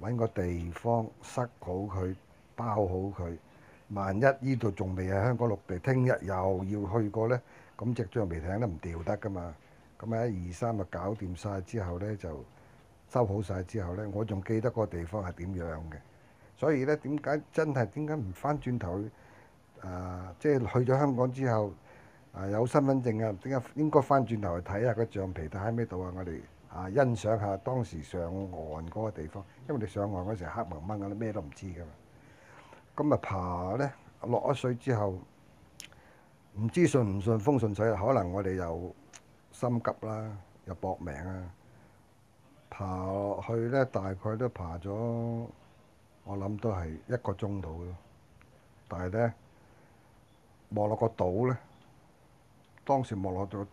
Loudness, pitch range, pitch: -32 LUFS, 95-120 Hz, 105 Hz